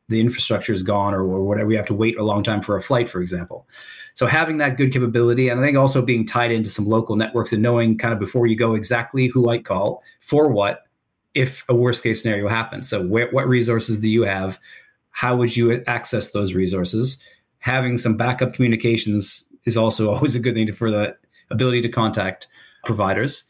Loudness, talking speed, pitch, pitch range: -19 LUFS, 210 wpm, 115 Hz, 110-125 Hz